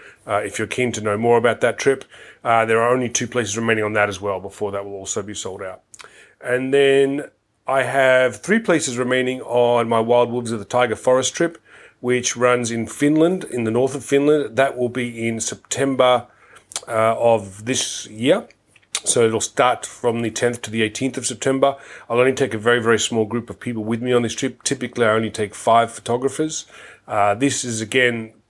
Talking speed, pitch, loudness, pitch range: 205 wpm, 120 Hz, -19 LUFS, 115-130 Hz